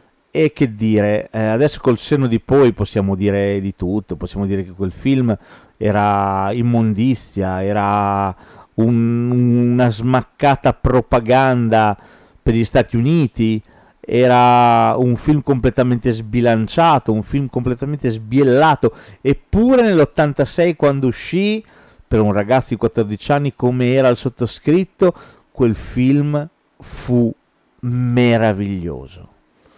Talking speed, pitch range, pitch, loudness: 110 wpm, 105-135 Hz, 120 Hz, -16 LUFS